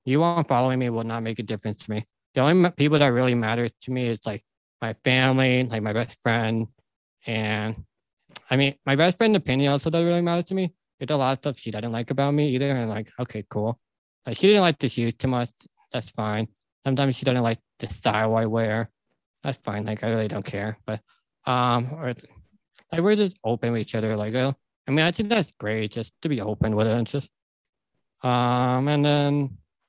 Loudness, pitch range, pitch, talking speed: -24 LUFS, 110-140 Hz, 125 Hz, 215 wpm